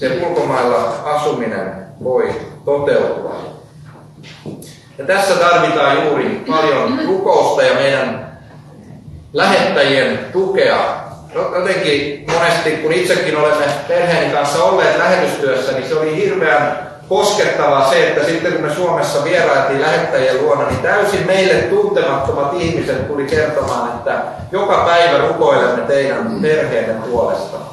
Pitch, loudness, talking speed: 175 Hz, -14 LUFS, 115 wpm